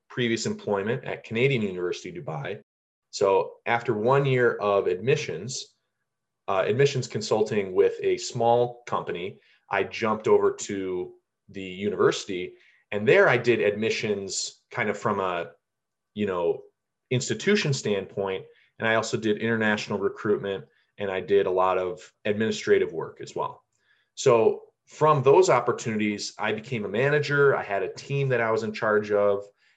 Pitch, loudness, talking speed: 150 Hz, -25 LUFS, 145 wpm